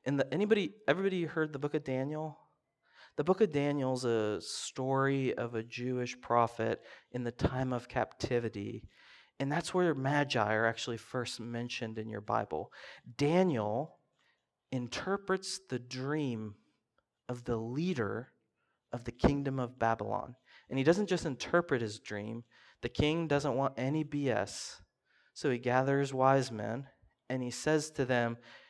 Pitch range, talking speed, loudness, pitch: 115-145 Hz, 145 wpm, -34 LUFS, 130 Hz